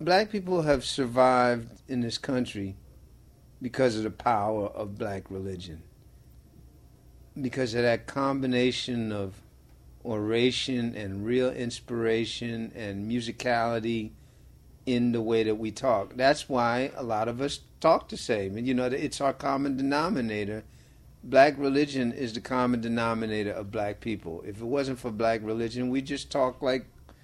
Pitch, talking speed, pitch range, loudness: 120 Hz, 145 wpm, 105-130 Hz, -28 LUFS